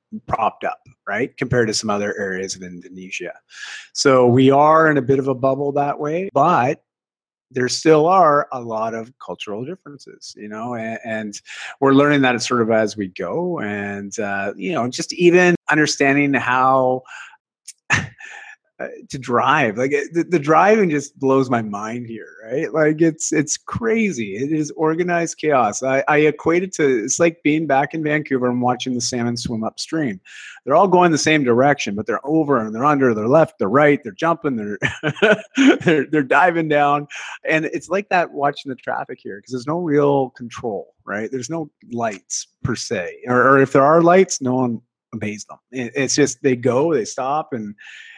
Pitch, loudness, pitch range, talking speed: 140 Hz, -18 LUFS, 120-160 Hz, 180 wpm